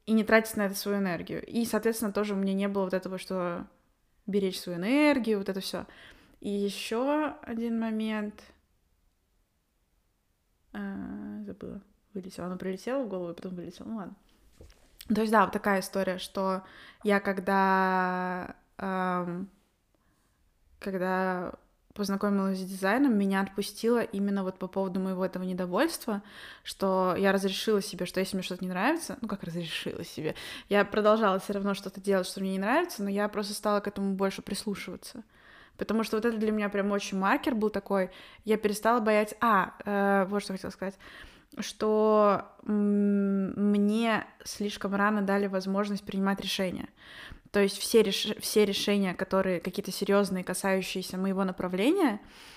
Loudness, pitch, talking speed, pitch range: -29 LUFS, 200 Hz, 155 wpm, 190-215 Hz